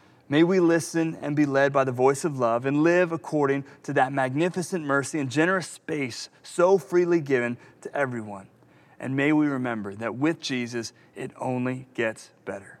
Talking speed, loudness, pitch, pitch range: 175 wpm, -25 LUFS, 140 Hz, 130-160 Hz